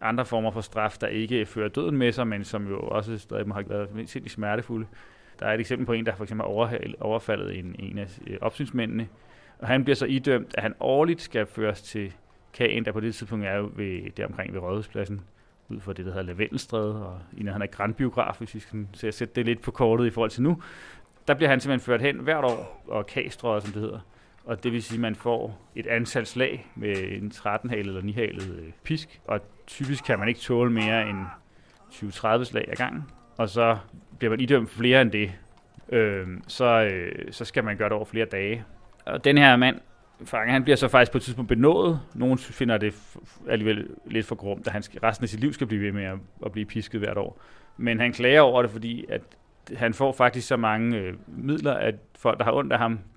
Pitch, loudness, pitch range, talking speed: 110 Hz, -26 LUFS, 105-125 Hz, 225 wpm